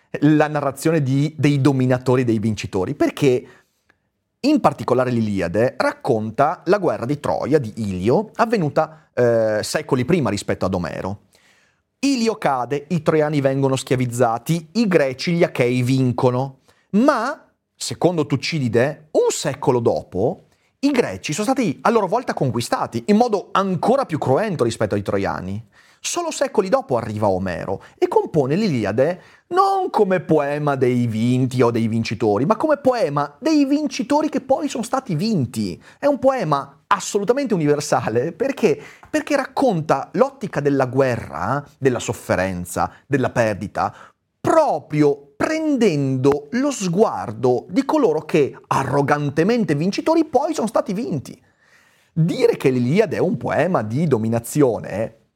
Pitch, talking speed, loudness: 150 Hz, 130 wpm, -20 LUFS